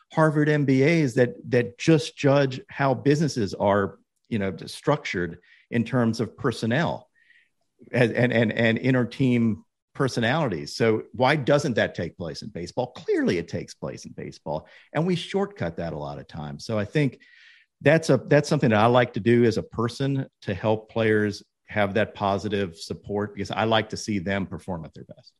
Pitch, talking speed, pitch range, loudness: 120 Hz, 180 wpm, 105-145 Hz, -24 LUFS